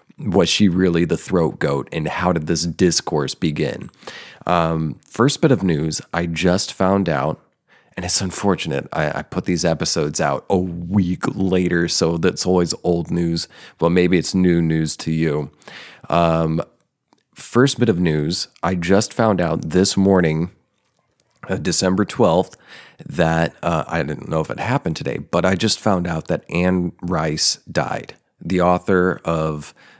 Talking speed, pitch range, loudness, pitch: 160 wpm, 80-95 Hz, -19 LUFS, 90 Hz